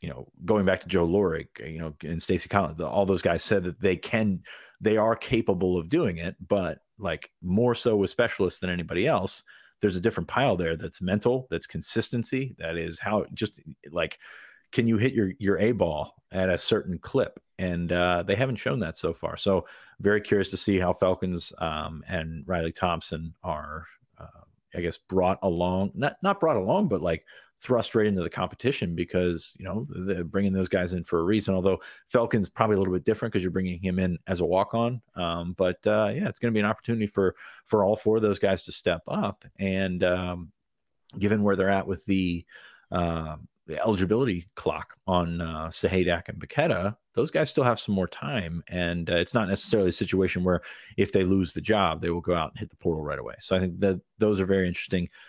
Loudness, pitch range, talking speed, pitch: -27 LUFS, 85-105 Hz, 215 wpm, 95 Hz